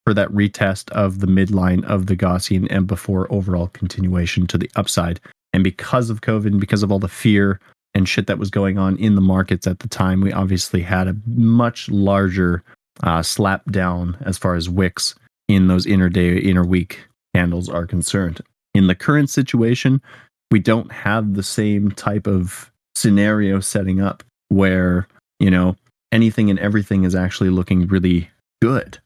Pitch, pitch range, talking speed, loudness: 95 Hz, 90-105 Hz, 175 wpm, -18 LUFS